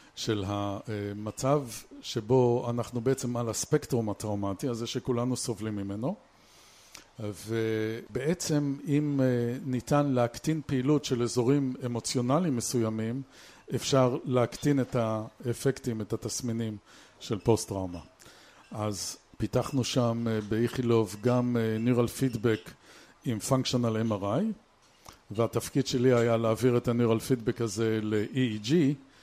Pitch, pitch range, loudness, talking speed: 120 Hz, 110-130 Hz, -29 LUFS, 100 wpm